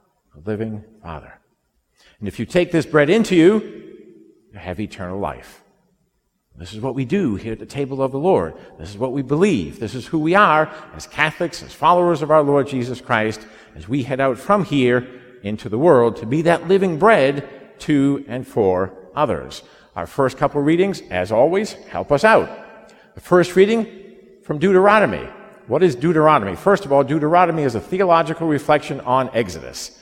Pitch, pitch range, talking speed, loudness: 145 Hz, 115-185 Hz, 180 wpm, -18 LUFS